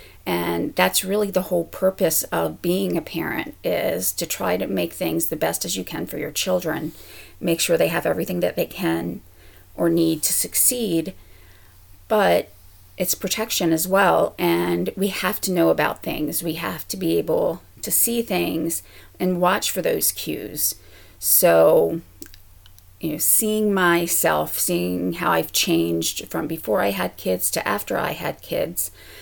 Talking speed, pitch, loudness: 165 wpm, 155 Hz, -21 LUFS